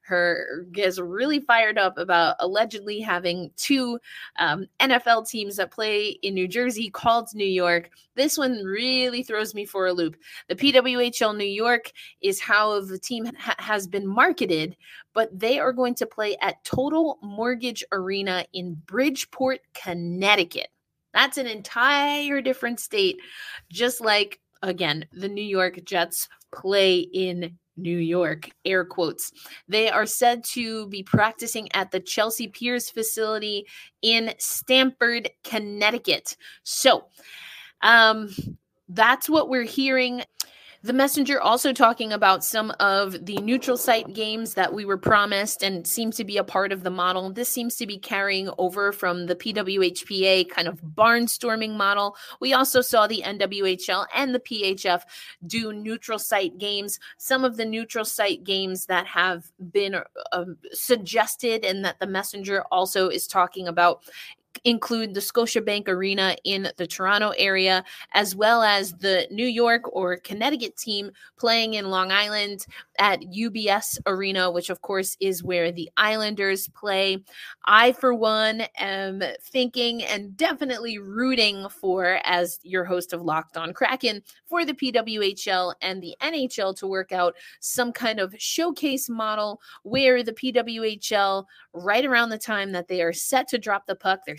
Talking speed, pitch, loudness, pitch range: 150 wpm, 205 Hz, -23 LUFS, 185-235 Hz